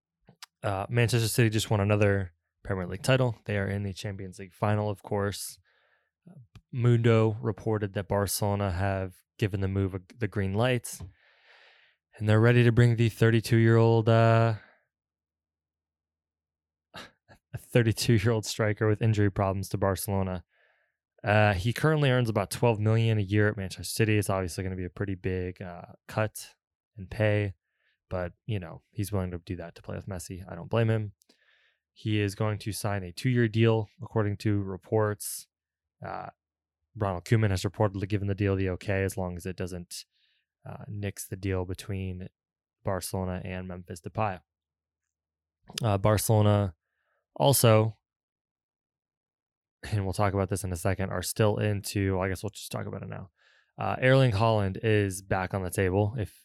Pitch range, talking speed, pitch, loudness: 95-110 Hz, 165 wpm, 100 Hz, -28 LUFS